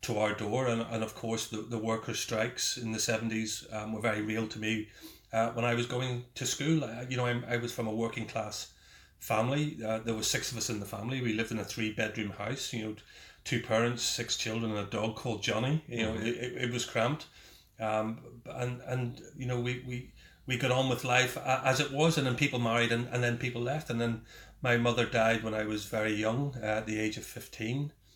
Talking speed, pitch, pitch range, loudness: 230 wpm, 115 Hz, 110-125 Hz, -32 LUFS